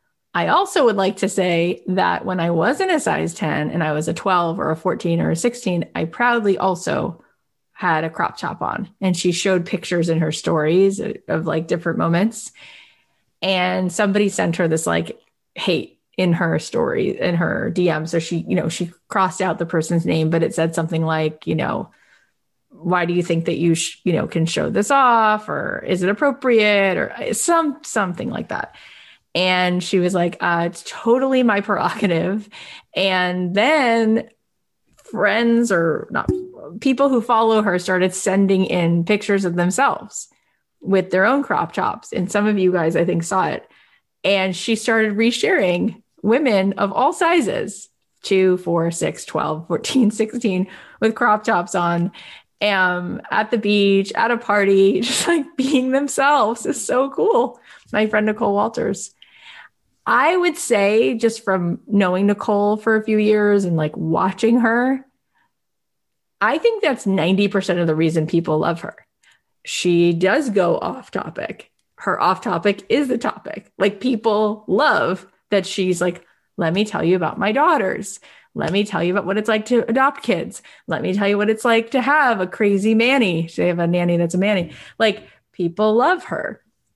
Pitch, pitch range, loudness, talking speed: 195 Hz, 175-225 Hz, -19 LUFS, 175 wpm